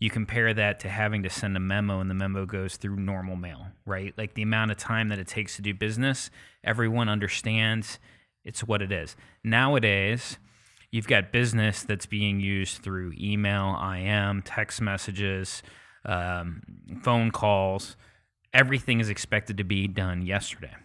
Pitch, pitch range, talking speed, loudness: 105 Hz, 95-110 Hz, 160 wpm, -27 LUFS